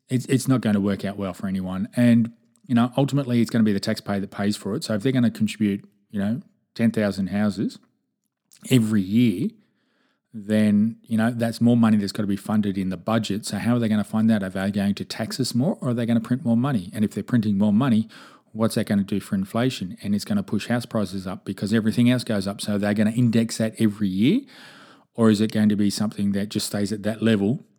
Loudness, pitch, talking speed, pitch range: -23 LUFS, 110 Hz, 260 wpm, 105-120 Hz